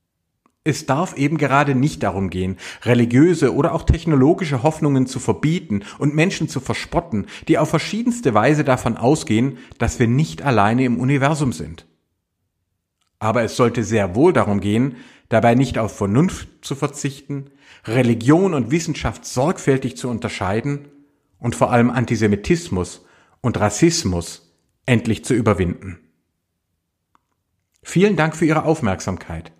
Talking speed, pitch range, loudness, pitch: 130 wpm, 100-145 Hz, -19 LUFS, 120 Hz